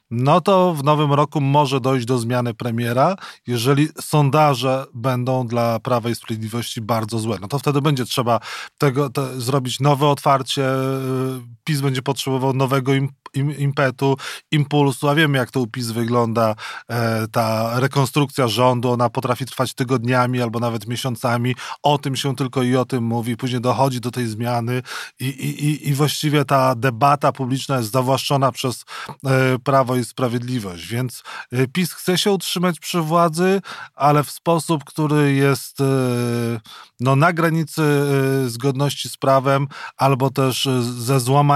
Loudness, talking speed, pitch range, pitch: -19 LUFS, 145 wpm, 125-145 Hz, 135 Hz